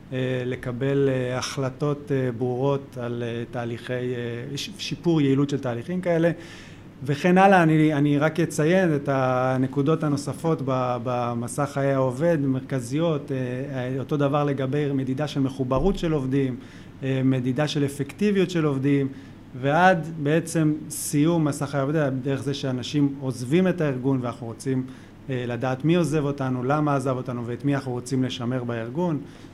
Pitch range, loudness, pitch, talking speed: 130-150 Hz, -24 LUFS, 140 Hz, 130 wpm